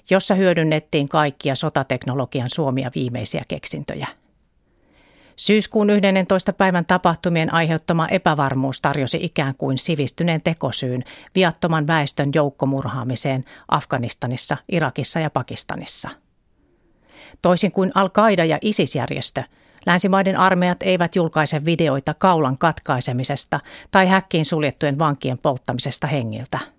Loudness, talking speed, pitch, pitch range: -20 LUFS, 95 wpm, 155 Hz, 135-180 Hz